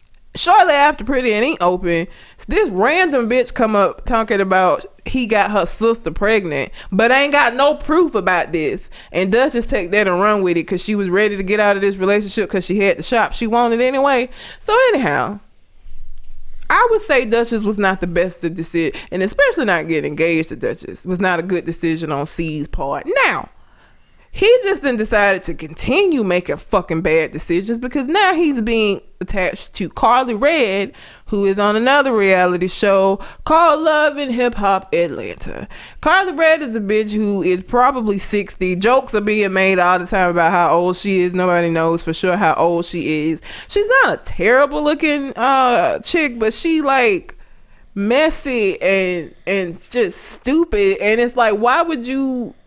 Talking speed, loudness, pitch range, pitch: 180 wpm, -16 LUFS, 180-270 Hz, 210 Hz